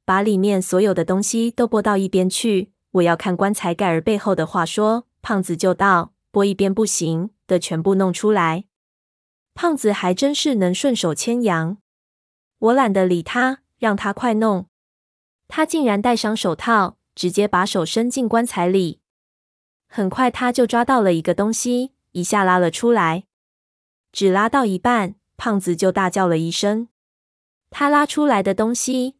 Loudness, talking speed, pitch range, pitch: -19 LUFS, 235 characters per minute, 185-235 Hz, 200 Hz